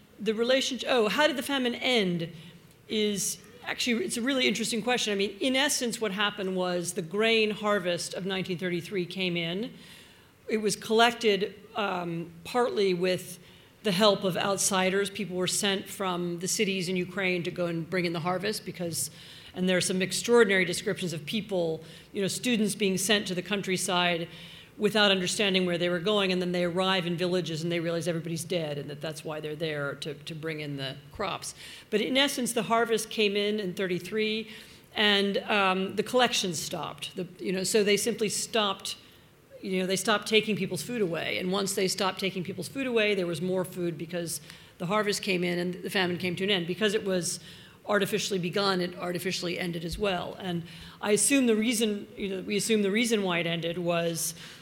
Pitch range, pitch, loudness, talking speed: 175-210 Hz, 190 Hz, -28 LUFS, 195 wpm